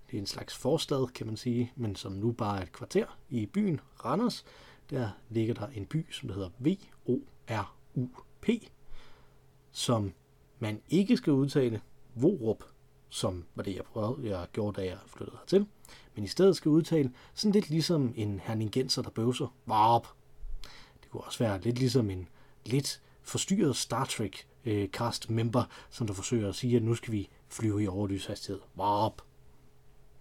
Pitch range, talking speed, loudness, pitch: 105-140 Hz, 160 wpm, -32 LUFS, 120 Hz